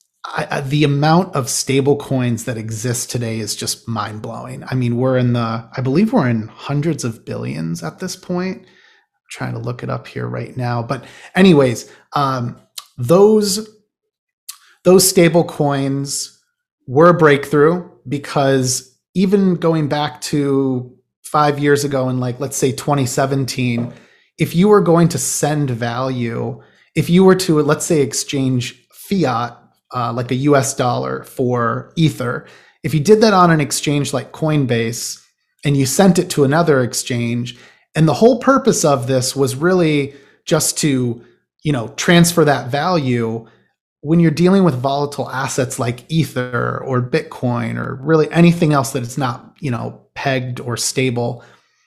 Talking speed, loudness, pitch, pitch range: 155 wpm, -16 LUFS, 140 Hz, 125-160 Hz